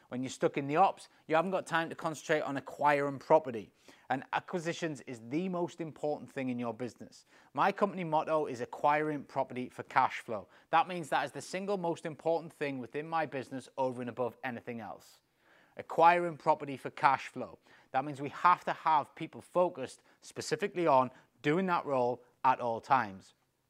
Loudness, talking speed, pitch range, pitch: -33 LUFS, 180 wpm, 130-165 Hz, 150 Hz